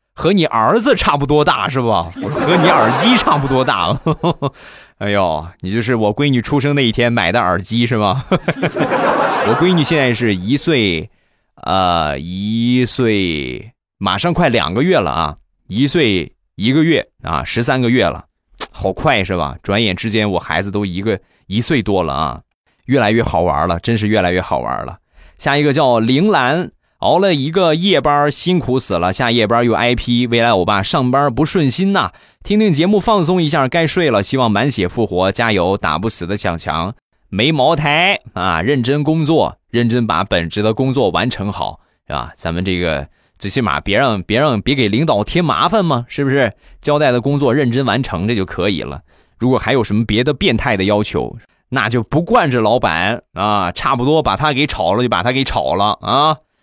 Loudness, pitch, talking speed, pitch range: -15 LUFS, 120 Hz, 265 characters per minute, 100-145 Hz